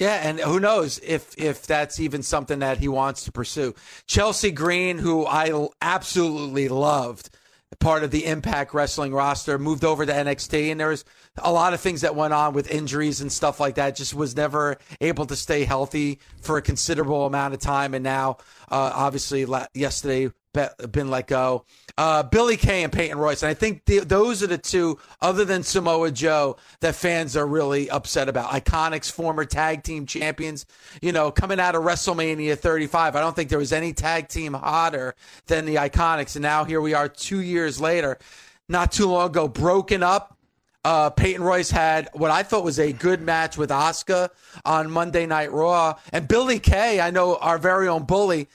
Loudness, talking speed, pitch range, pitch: -23 LUFS, 195 wpm, 145-170 Hz, 155 Hz